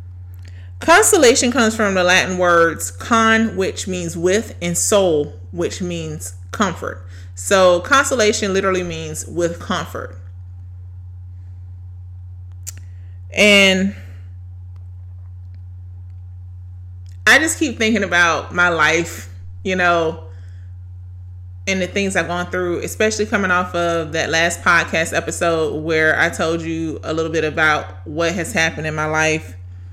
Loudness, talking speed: -16 LUFS, 120 wpm